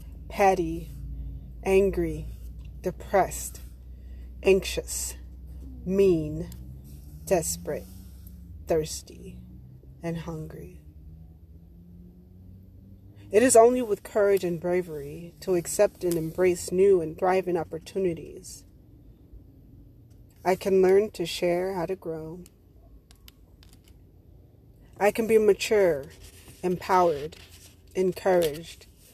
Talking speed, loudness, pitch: 80 wpm, -25 LUFS, 115 Hz